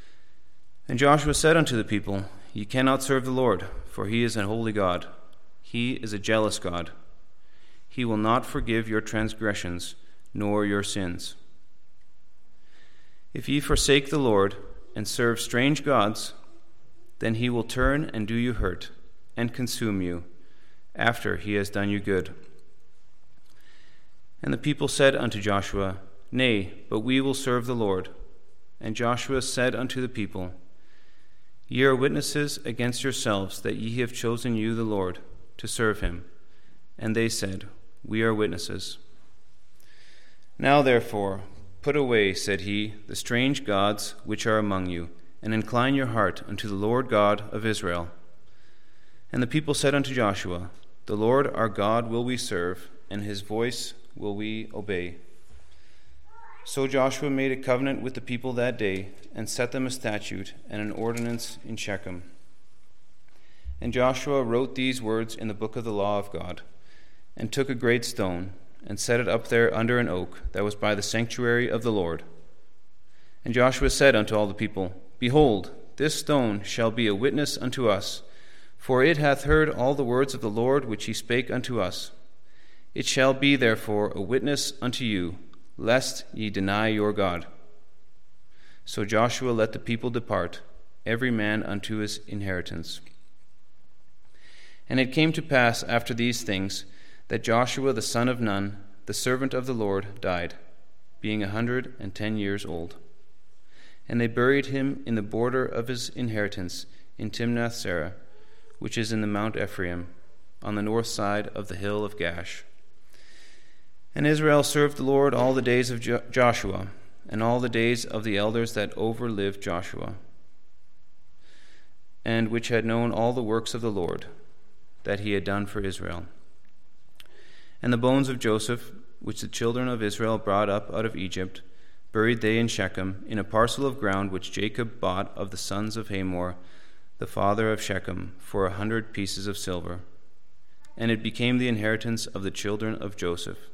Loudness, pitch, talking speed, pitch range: -26 LUFS, 110 Hz, 165 wpm, 100-125 Hz